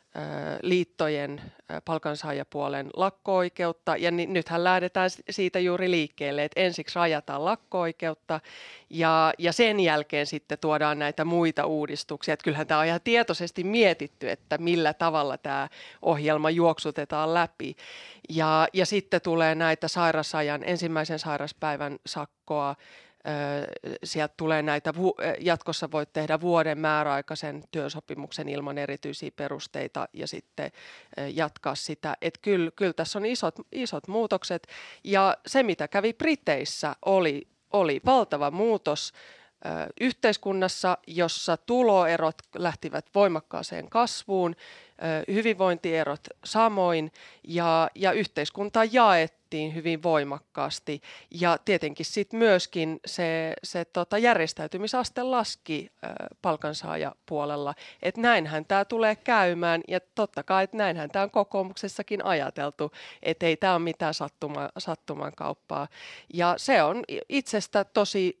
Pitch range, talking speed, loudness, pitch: 155-190 Hz, 115 wpm, -27 LUFS, 165 Hz